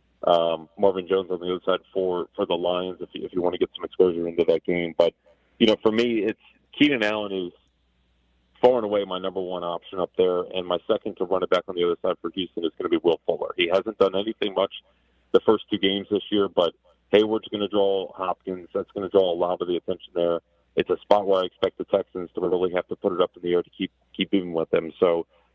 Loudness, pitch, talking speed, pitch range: -24 LUFS, 95 Hz, 265 wpm, 85-110 Hz